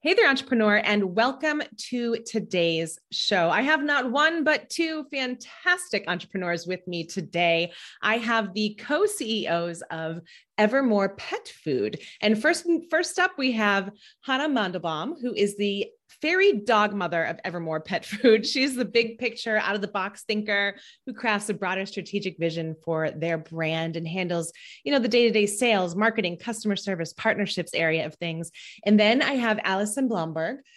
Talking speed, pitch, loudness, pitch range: 165 wpm, 210 Hz, -25 LUFS, 180-255 Hz